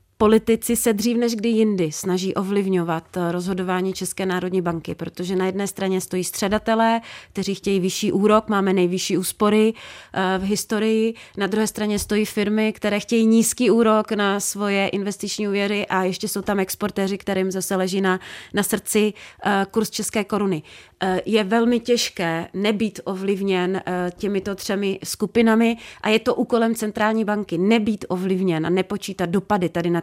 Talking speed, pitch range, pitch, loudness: 150 wpm, 185-215 Hz, 200 Hz, -21 LUFS